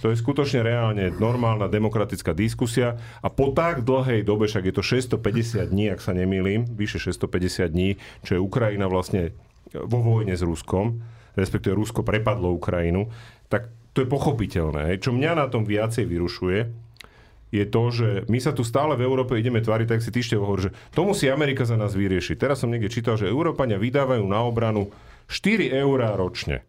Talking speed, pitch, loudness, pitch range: 180 wpm, 110 Hz, -24 LUFS, 100-120 Hz